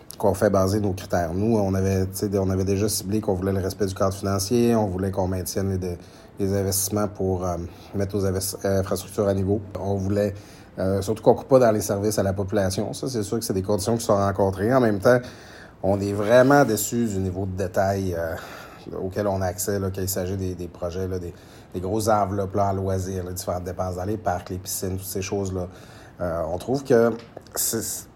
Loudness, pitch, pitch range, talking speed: -24 LUFS, 100 Hz, 95-105 Hz, 220 wpm